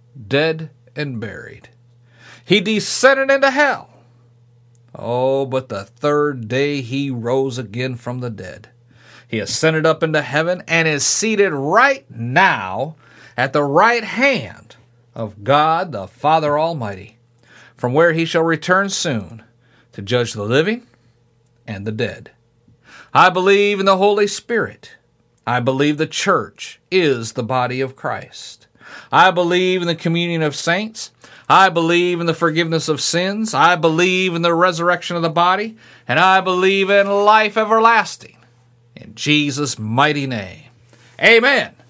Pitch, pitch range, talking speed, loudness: 145 Hz, 120-175 Hz, 140 wpm, -16 LUFS